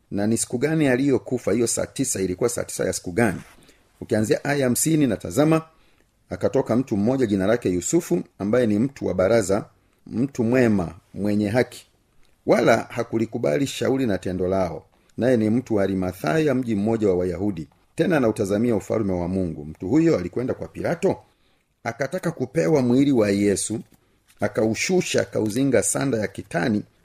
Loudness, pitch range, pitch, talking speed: -22 LUFS, 100-135 Hz, 115 Hz, 155 wpm